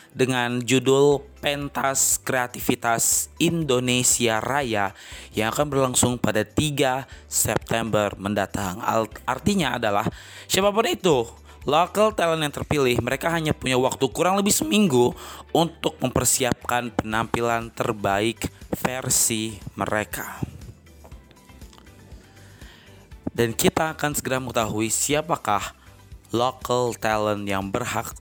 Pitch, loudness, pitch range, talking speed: 120 Hz, -23 LUFS, 100-135 Hz, 95 wpm